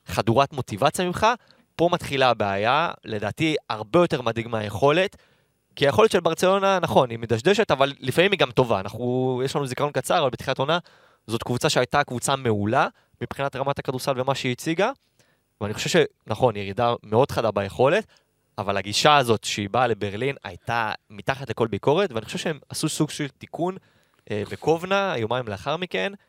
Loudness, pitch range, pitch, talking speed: -23 LUFS, 115-160 Hz, 135 Hz, 165 wpm